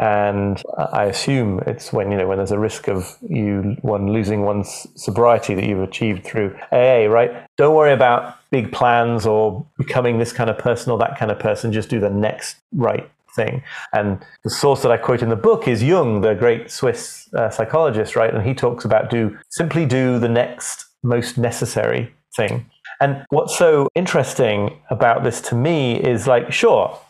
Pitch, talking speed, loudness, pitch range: 115 Hz, 190 wpm, -18 LUFS, 105-125 Hz